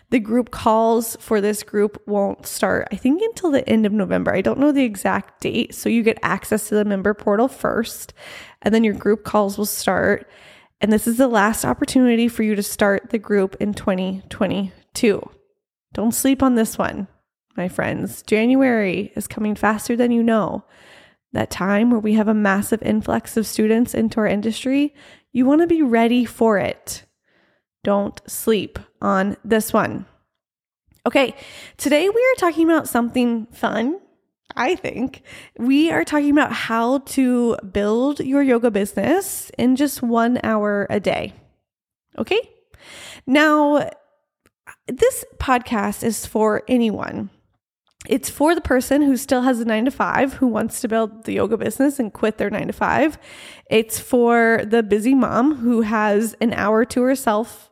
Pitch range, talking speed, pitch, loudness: 215-270 Hz, 165 wpm, 230 Hz, -19 LUFS